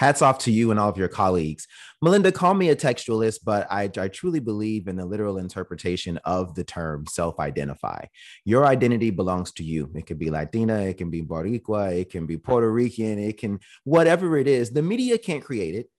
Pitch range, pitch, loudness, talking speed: 90-125 Hz, 105 Hz, -24 LUFS, 210 wpm